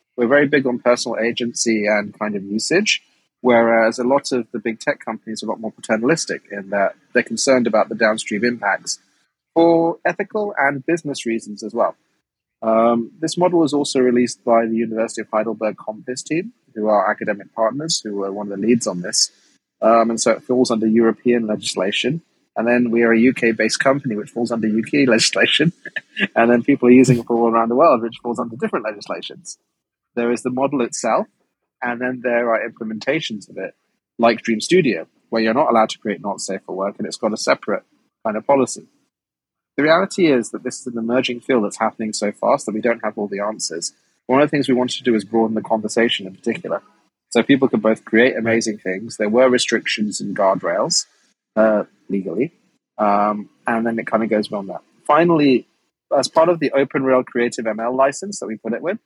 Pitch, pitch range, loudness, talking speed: 115 Hz, 110-130 Hz, -19 LUFS, 205 wpm